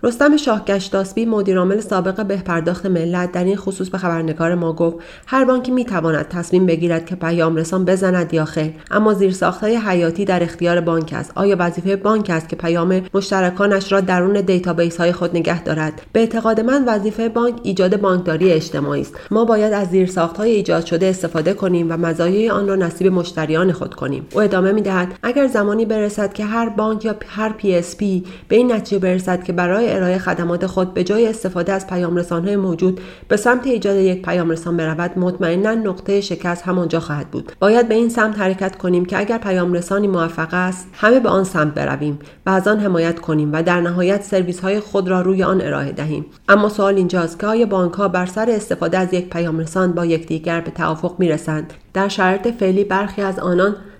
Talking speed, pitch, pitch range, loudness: 195 wpm, 185 Hz, 170-200 Hz, -17 LUFS